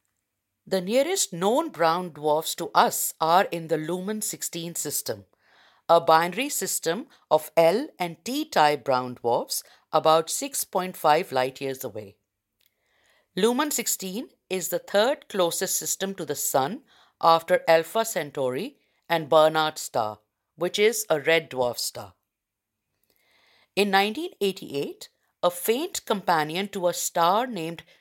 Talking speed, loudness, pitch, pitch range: 125 wpm, -25 LUFS, 170 Hz, 150-200 Hz